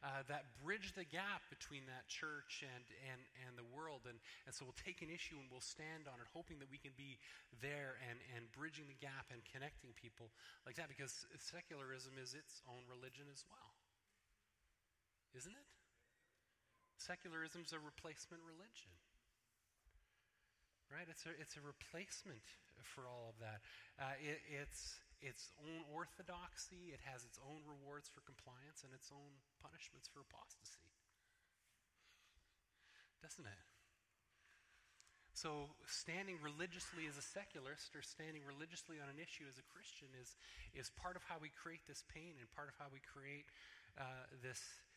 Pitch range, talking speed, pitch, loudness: 130-160 Hz, 155 wpm, 145 Hz, -54 LUFS